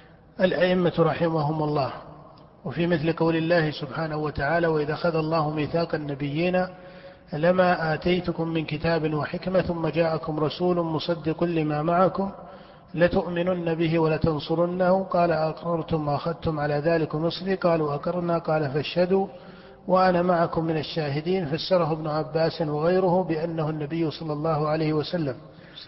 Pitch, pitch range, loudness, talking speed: 165 Hz, 155-175 Hz, -25 LUFS, 120 wpm